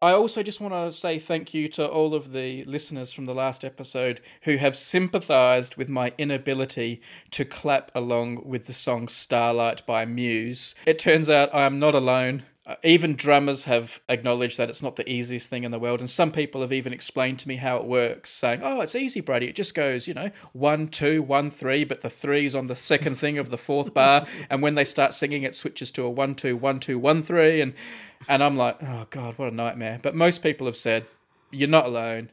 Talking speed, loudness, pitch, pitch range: 225 wpm, -24 LUFS, 135 Hz, 125-150 Hz